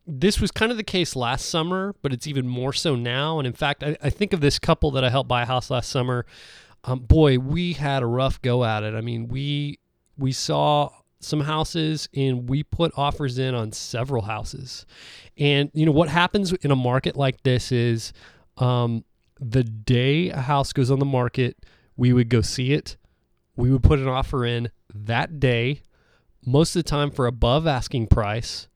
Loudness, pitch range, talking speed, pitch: -23 LUFS, 120-145 Hz, 200 wpm, 130 Hz